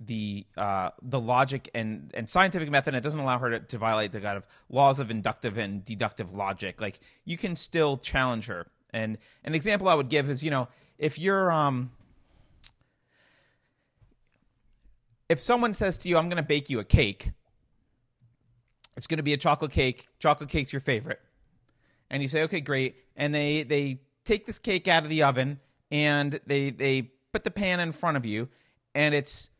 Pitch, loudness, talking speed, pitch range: 135 Hz, -28 LUFS, 180 wpm, 115-150 Hz